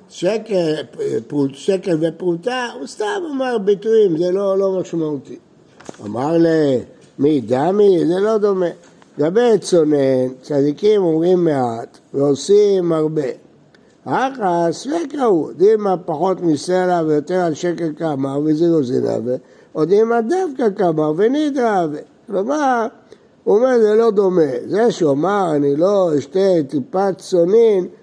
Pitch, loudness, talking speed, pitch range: 180 Hz, -17 LUFS, 115 wpm, 155-220 Hz